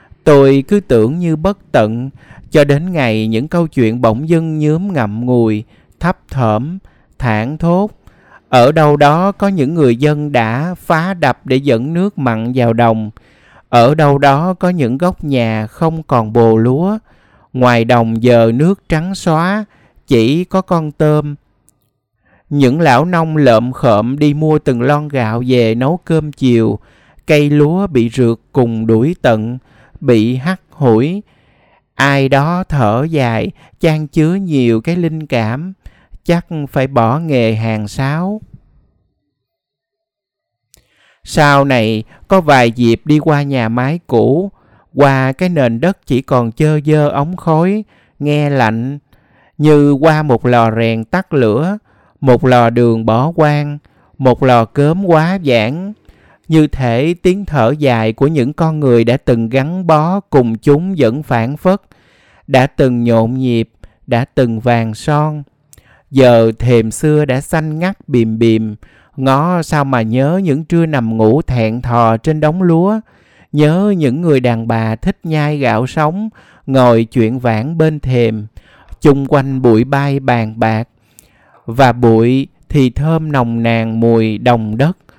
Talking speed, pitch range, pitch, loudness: 150 wpm, 115-155 Hz, 135 Hz, -12 LUFS